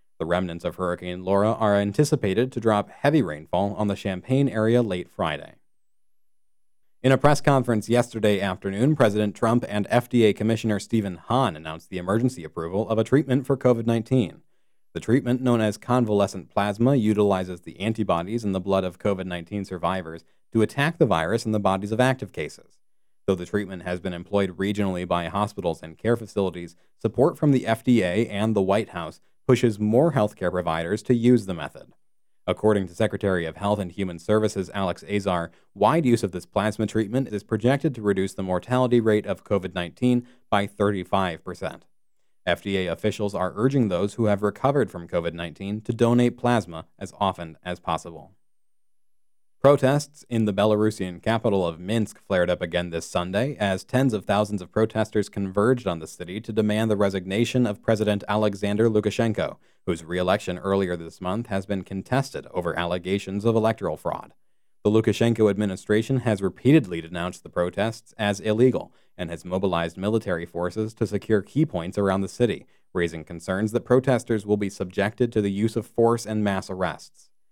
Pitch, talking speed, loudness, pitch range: 105 Hz, 170 wpm, -24 LUFS, 95-115 Hz